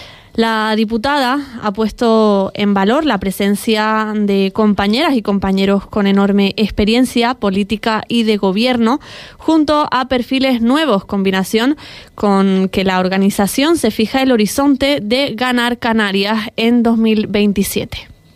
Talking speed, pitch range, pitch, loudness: 120 wpm, 200-250 Hz, 220 Hz, -14 LUFS